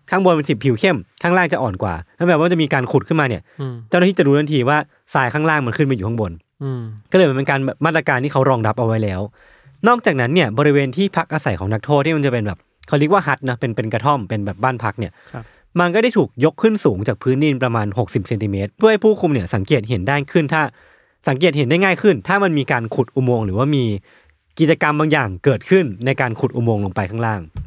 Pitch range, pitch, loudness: 115-160 Hz, 135 Hz, -17 LUFS